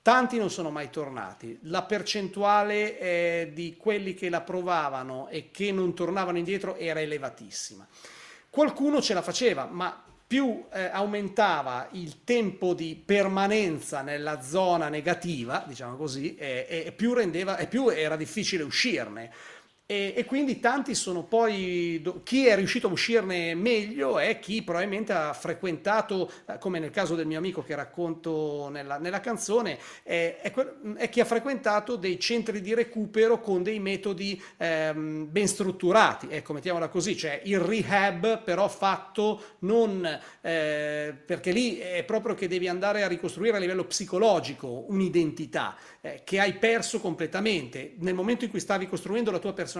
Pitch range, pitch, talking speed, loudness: 165-210 Hz, 185 Hz, 150 wpm, -28 LUFS